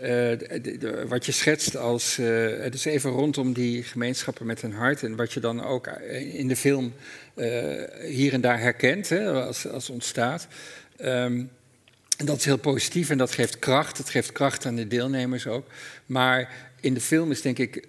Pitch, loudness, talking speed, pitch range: 130 Hz, -26 LUFS, 195 wpm, 120-140 Hz